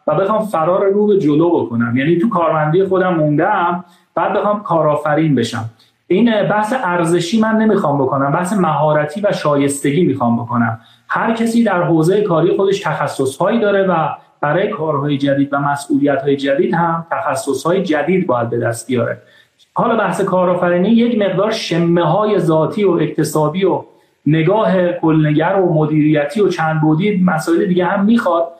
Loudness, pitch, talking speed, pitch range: -15 LUFS, 170 Hz, 155 wpm, 150-195 Hz